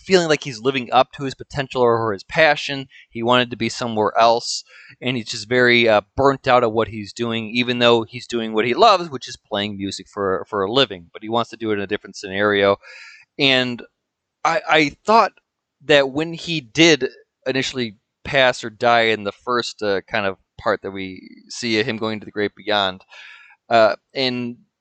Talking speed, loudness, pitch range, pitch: 205 wpm, -19 LUFS, 110-135 Hz, 120 Hz